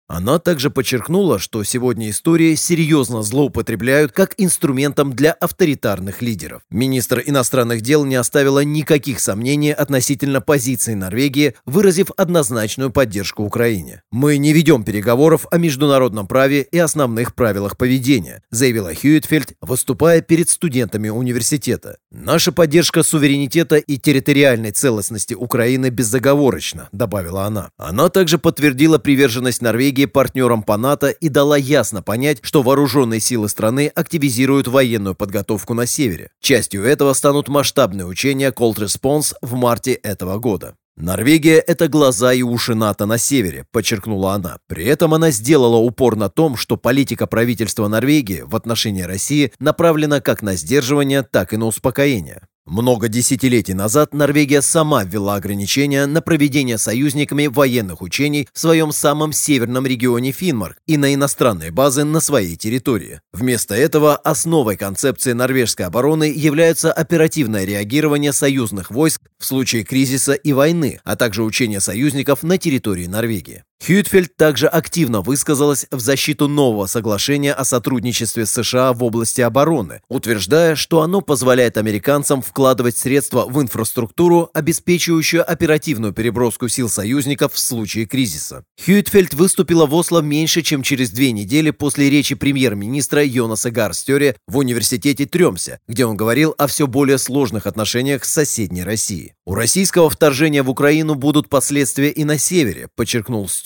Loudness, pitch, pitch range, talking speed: -16 LUFS, 135 Hz, 115-150 Hz, 140 wpm